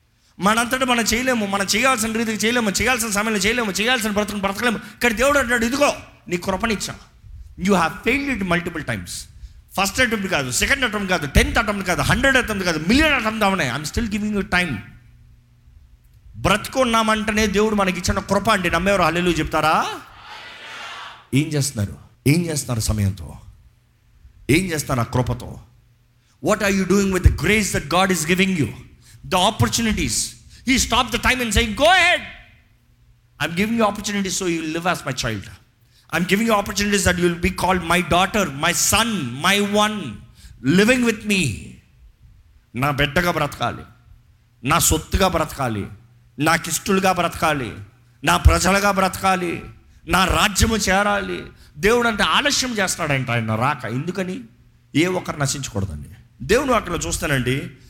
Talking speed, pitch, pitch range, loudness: 140 wpm, 180 Hz, 125-210 Hz, -19 LUFS